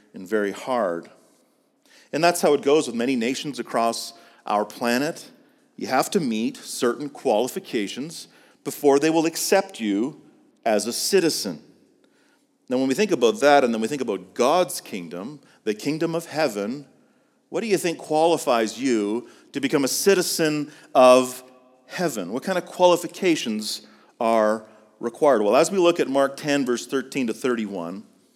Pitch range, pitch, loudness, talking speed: 120-175 Hz, 145 Hz, -22 LUFS, 155 wpm